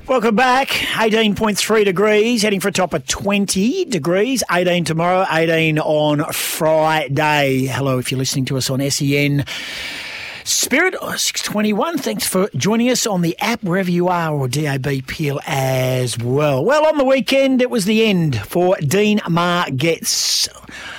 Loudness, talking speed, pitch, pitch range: -17 LUFS, 150 wpm, 175 Hz, 145-215 Hz